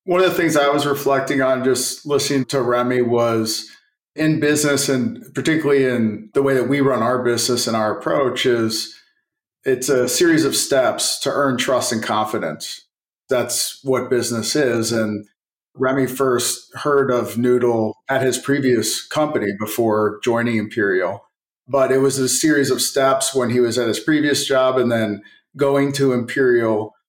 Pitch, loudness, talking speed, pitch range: 130 Hz, -18 LUFS, 165 wpm, 120-140 Hz